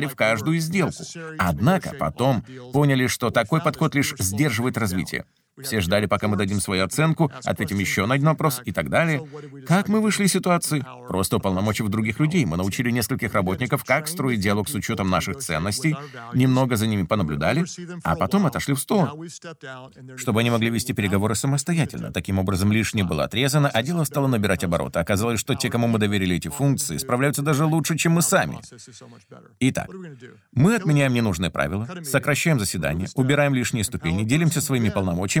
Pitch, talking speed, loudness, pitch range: 130 Hz, 170 wpm, -22 LUFS, 105-155 Hz